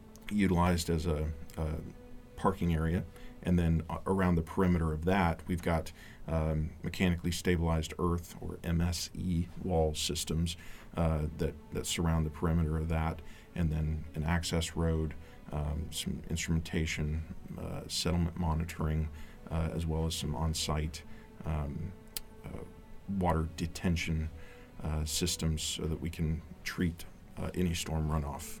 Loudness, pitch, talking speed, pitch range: -34 LUFS, 80 Hz, 135 wpm, 80-90 Hz